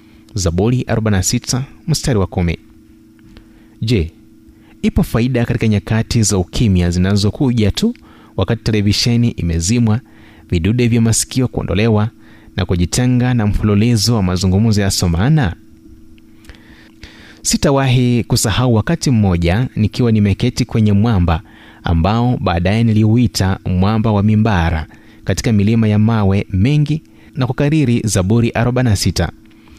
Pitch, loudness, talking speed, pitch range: 110 Hz, -15 LUFS, 105 wpm, 95-120 Hz